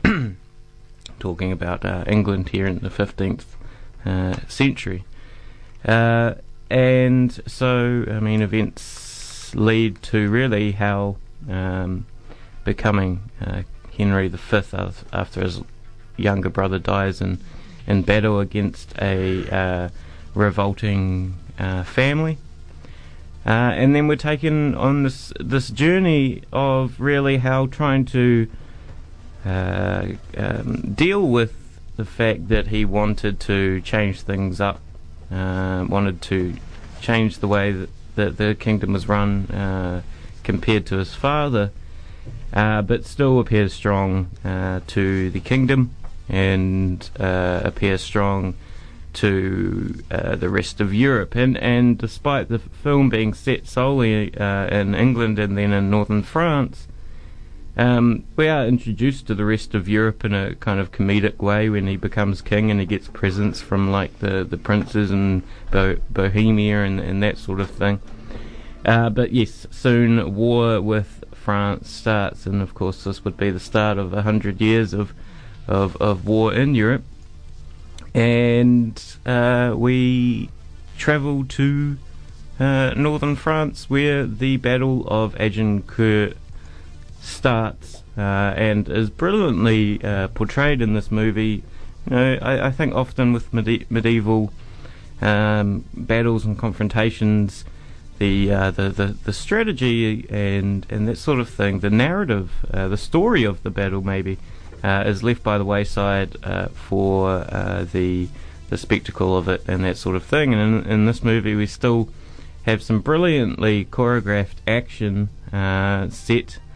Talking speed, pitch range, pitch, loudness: 140 wpm, 95-115 Hz, 105 Hz, -20 LUFS